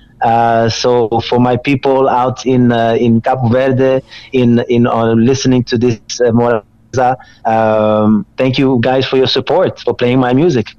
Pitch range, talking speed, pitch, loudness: 115-130 Hz, 160 wpm, 120 Hz, -12 LUFS